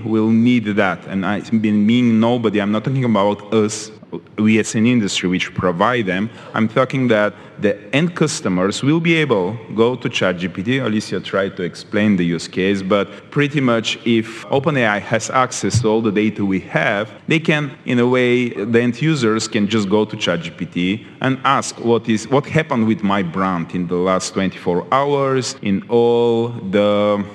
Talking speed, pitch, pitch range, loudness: 185 wpm, 110 Hz, 100-120 Hz, -17 LUFS